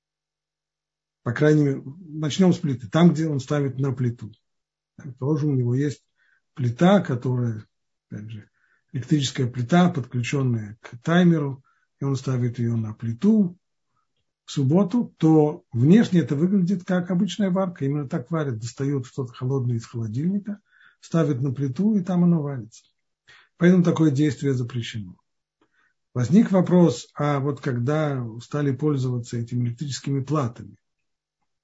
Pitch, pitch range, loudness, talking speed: 140 Hz, 125-165 Hz, -23 LUFS, 135 wpm